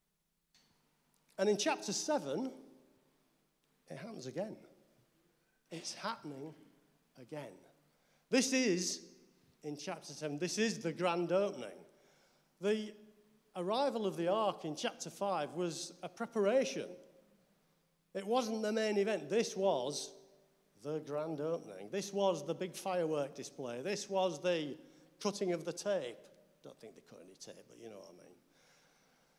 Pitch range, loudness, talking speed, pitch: 170-205 Hz, -37 LUFS, 135 wpm, 185 Hz